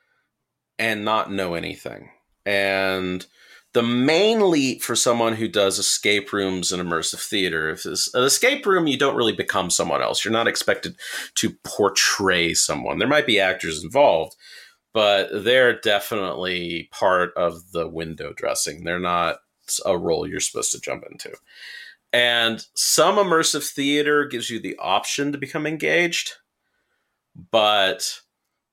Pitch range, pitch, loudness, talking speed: 90-130 Hz, 105 Hz, -21 LUFS, 140 wpm